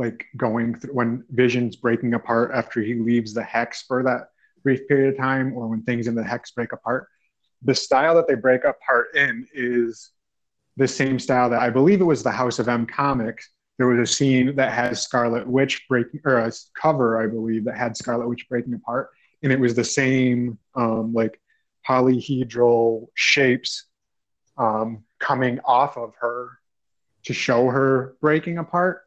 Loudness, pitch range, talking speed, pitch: -21 LUFS, 115-130 Hz, 180 wpm, 125 Hz